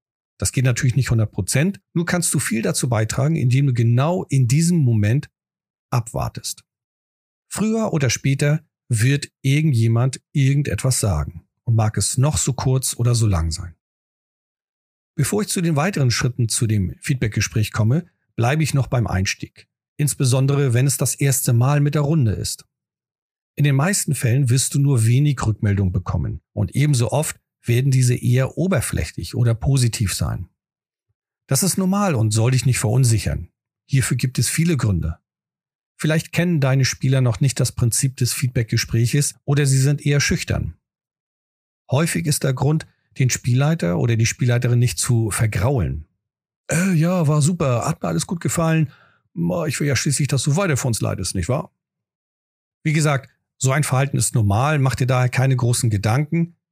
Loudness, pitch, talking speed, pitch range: -20 LUFS, 130 Hz, 165 wpm, 115-145 Hz